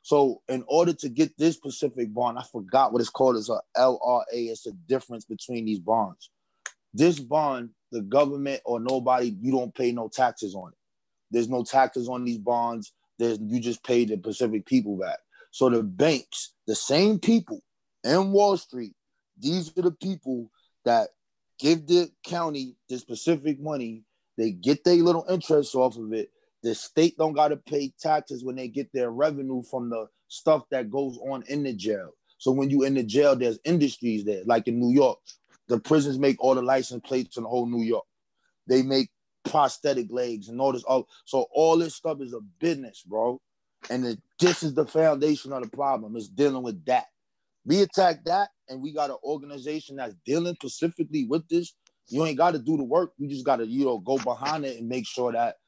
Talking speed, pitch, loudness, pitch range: 195 wpm, 135 Hz, -26 LUFS, 120-155 Hz